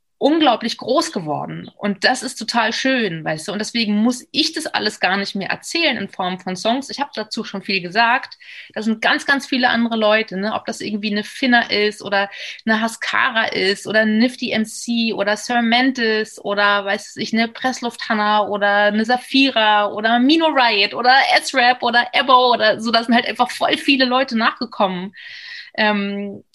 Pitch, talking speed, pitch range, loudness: 225 Hz, 180 wpm, 205-250 Hz, -17 LUFS